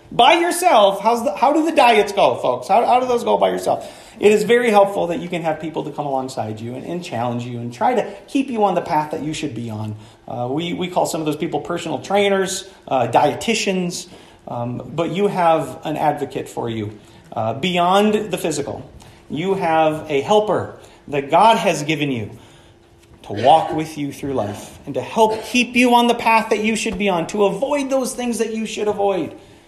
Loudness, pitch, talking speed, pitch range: -18 LUFS, 175 Hz, 215 wpm, 140-220 Hz